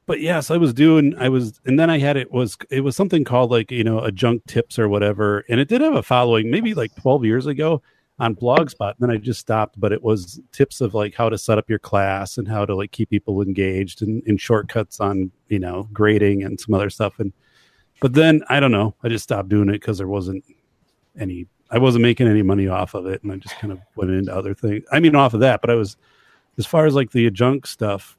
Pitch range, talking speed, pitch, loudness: 100-130 Hz, 260 wpm, 110 Hz, -19 LUFS